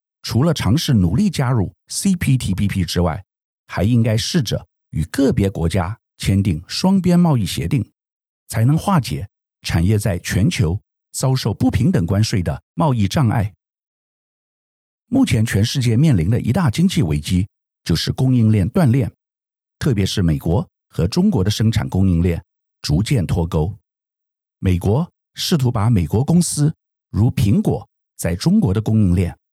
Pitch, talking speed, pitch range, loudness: 110 Hz, 230 characters per minute, 90-130 Hz, -18 LUFS